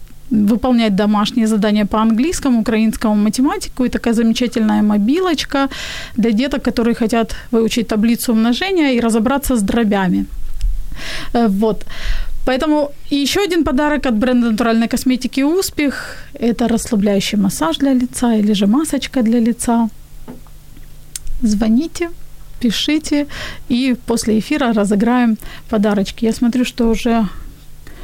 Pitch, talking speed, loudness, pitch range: 235 Hz, 115 wpm, -16 LUFS, 220-265 Hz